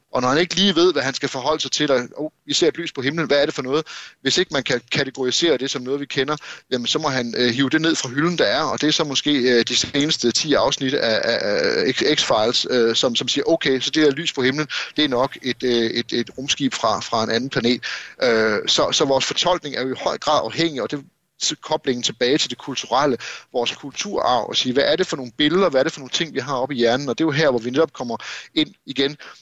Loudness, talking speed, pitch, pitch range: -20 LUFS, 255 wpm, 140 Hz, 125-155 Hz